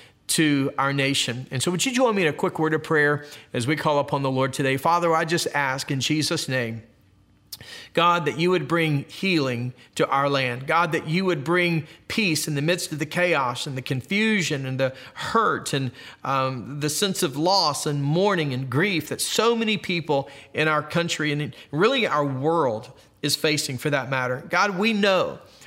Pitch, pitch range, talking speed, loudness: 150 Hz, 135-170 Hz, 200 wpm, -23 LUFS